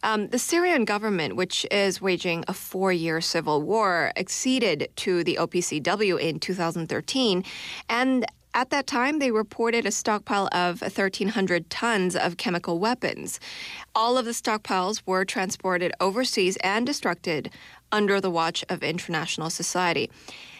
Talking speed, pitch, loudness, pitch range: 135 wpm, 190 Hz, -25 LUFS, 175-225 Hz